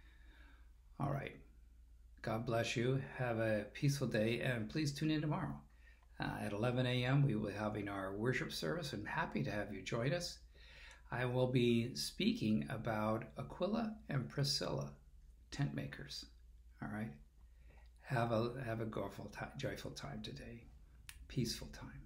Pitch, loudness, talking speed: 105 Hz, -40 LUFS, 150 wpm